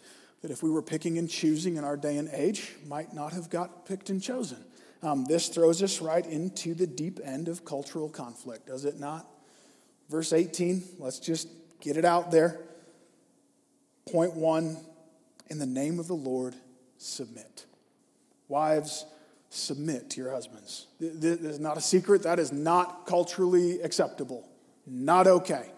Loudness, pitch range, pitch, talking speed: -29 LUFS, 150-175 Hz, 165 Hz, 155 wpm